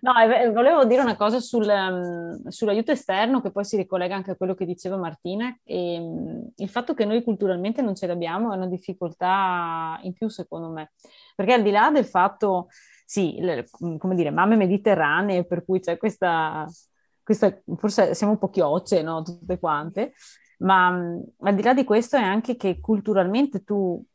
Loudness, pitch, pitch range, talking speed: -23 LUFS, 195 Hz, 180-220 Hz, 180 wpm